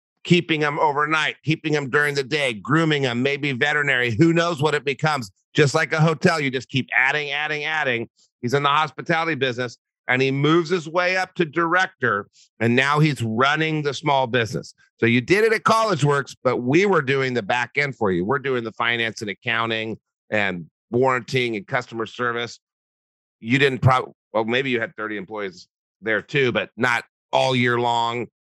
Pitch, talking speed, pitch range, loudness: 135 Hz, 190 wpm, 120-155 Hz, -21 LUFS